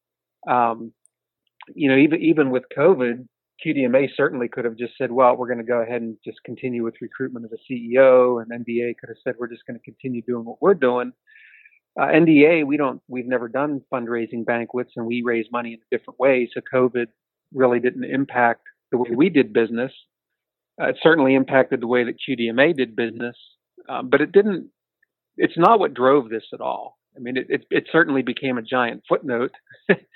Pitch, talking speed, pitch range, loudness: 125 Hz, 195 wpm, 120-135 Hz, -20 LUFS